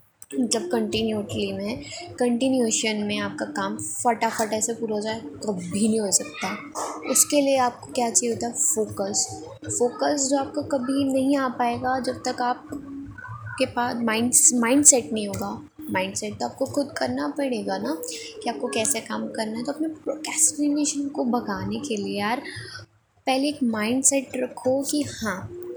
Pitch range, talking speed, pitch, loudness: 220-275 Hz, 170 wpm, 245 Hz, -23 LUFS